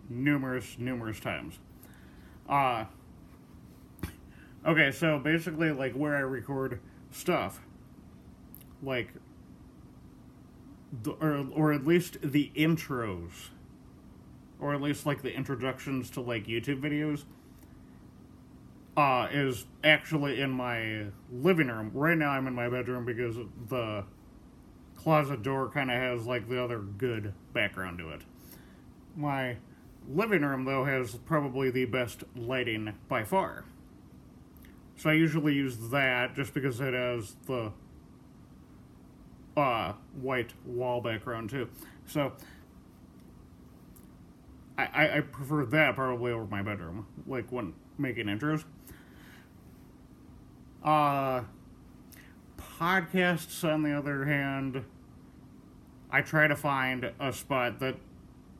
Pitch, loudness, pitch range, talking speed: 125 Hz, -31 LUFS, 105-145 Hz, 115 wpm